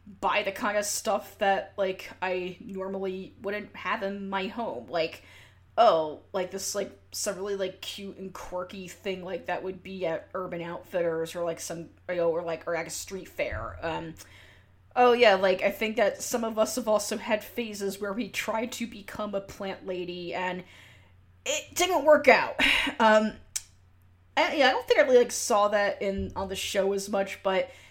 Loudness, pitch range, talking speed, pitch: -28 LUFS, 170-210 Hz, 195 wpm, 195 Hz